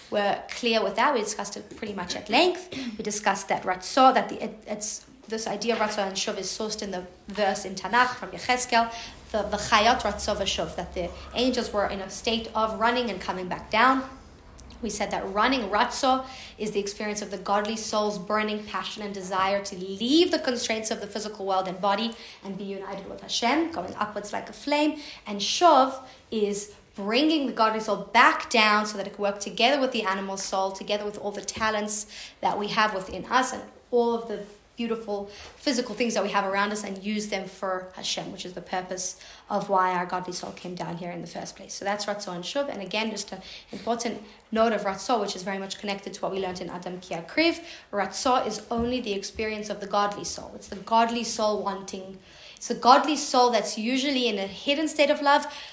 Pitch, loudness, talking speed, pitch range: 210 Hz, -26 LUFS, 220 wpm, 195-235 Hz